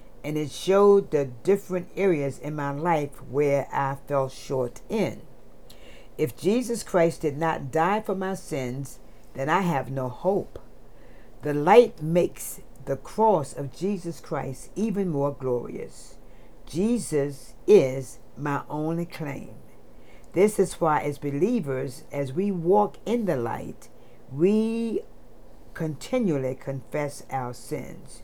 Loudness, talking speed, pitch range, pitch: -26 LUFS, 130 wpm, 135-190 Hz, 150 Hz